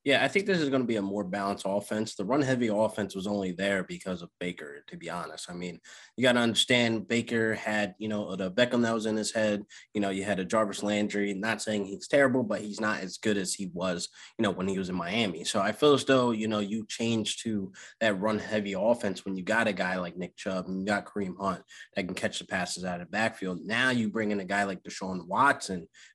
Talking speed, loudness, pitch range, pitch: 255 wpm, -29 LUFS, 95-110 Hz, 105 Hz